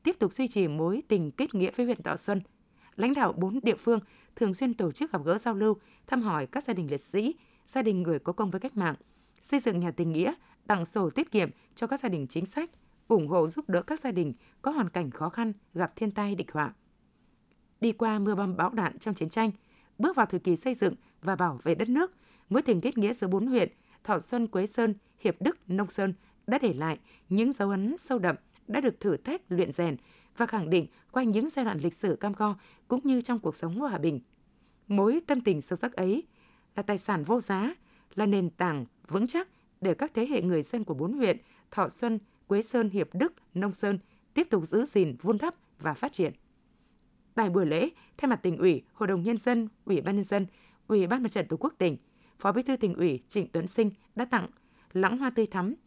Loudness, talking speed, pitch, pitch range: -29 LUFS, 235 wpm, 210 Hz, 185-235 Hz